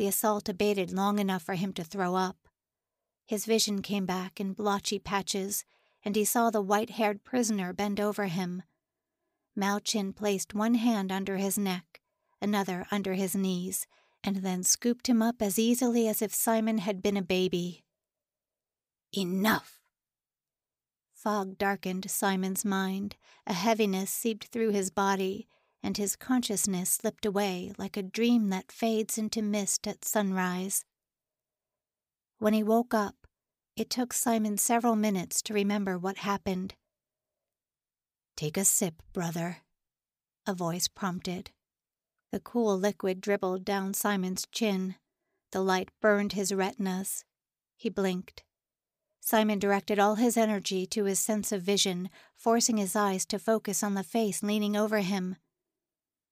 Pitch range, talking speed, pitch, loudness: 190-220 Hz, 140 wpm, 205 Hz, -30 LUFS